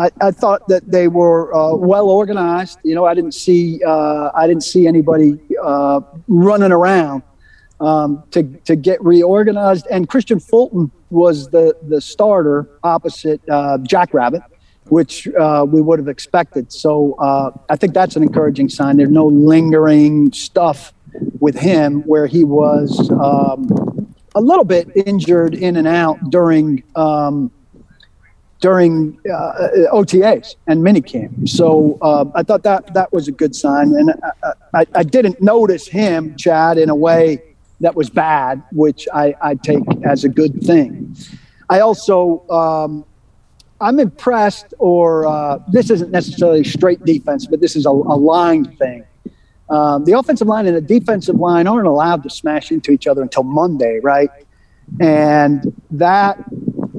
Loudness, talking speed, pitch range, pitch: -13 LUFS, 155 wpm, 150-185 Hz, 165 Hz